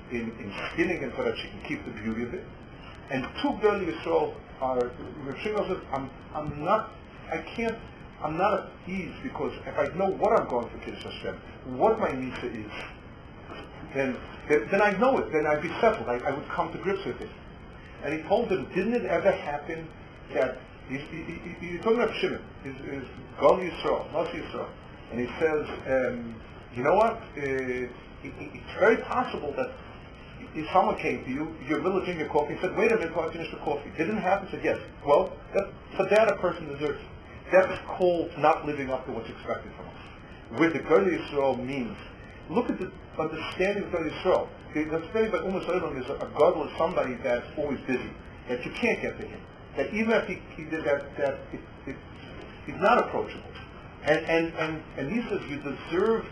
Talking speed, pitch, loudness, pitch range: 195 wpm, 160 Hz, -28 LUFS, 135-190 Hz